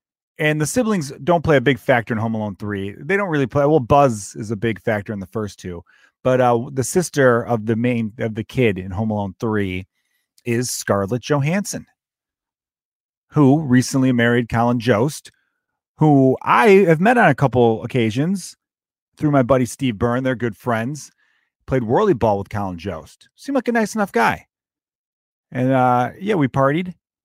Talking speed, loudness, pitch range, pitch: 180 wpm, -18 LUFS, 115-145 Hz, 125 Hz